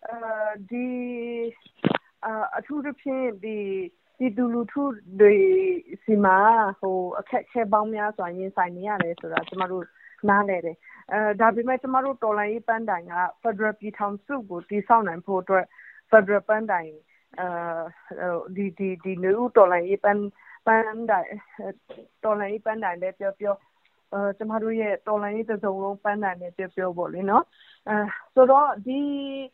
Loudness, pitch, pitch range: -24 LUFS, 210 Hz, 190-230 Hz